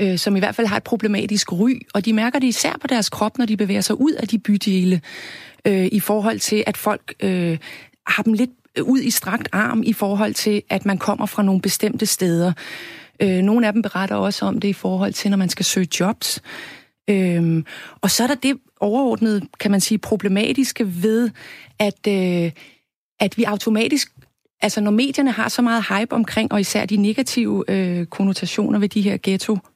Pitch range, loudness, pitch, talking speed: 195-230 Hz, -19 LUFS, 210 Hz, 200 wpm